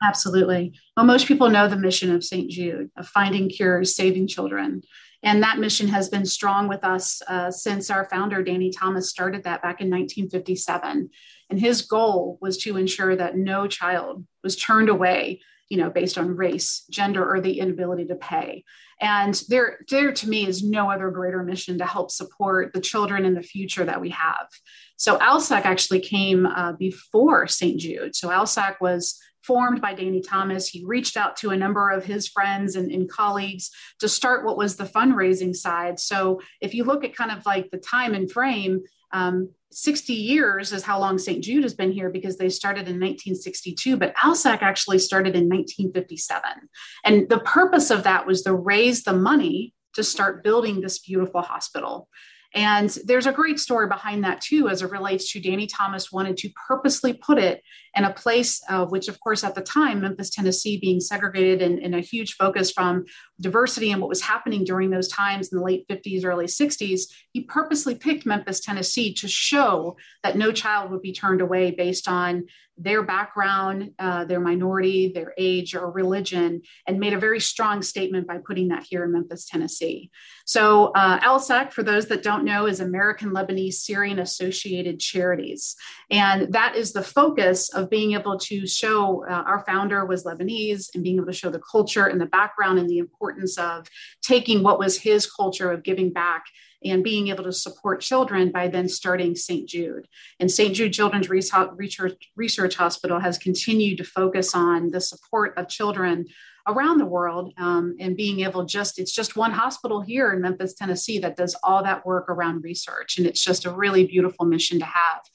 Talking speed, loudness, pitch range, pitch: 190 wpm, -22 LUFS, 185-210 Hz, 190 Hz